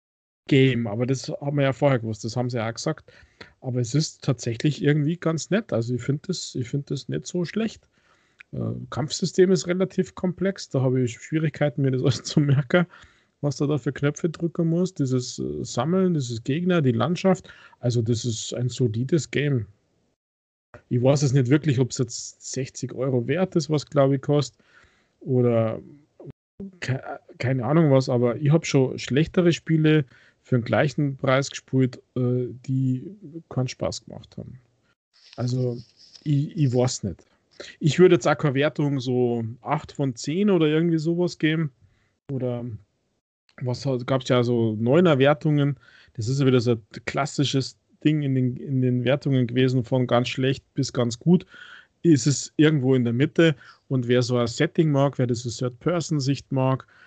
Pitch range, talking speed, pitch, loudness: 125-155 Hz, 170 wpm, 135 Hz, -24 LUFS